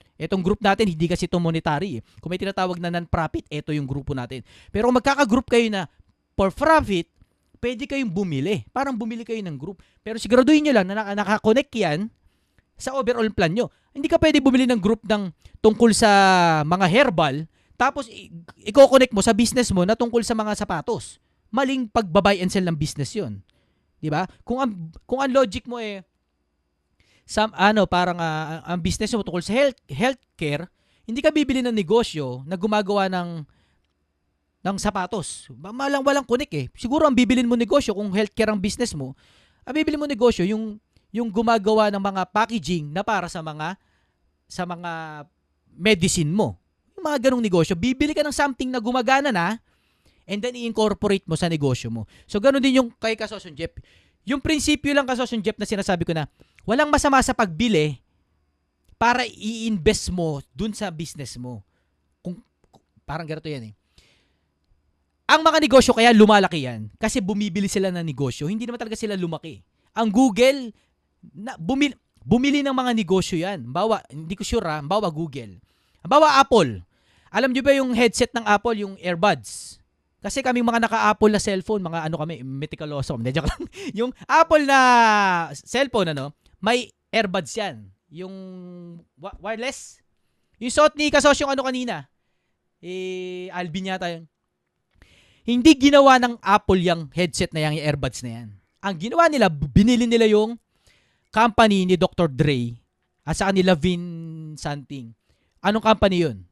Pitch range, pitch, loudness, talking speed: 155-240 Hz, 200 Hz, -21 LUFS, 165 wpm